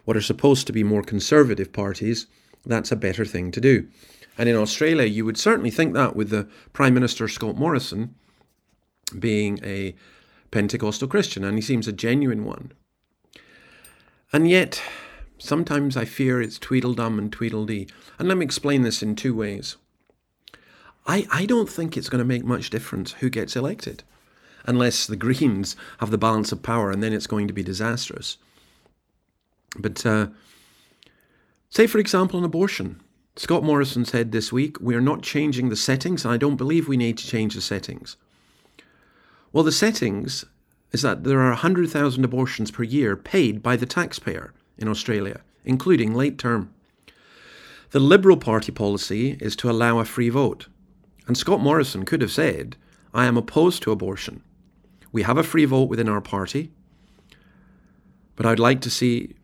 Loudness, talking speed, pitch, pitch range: -22 LUFS, 165 wpm, 120 Hz, 110-140 Hz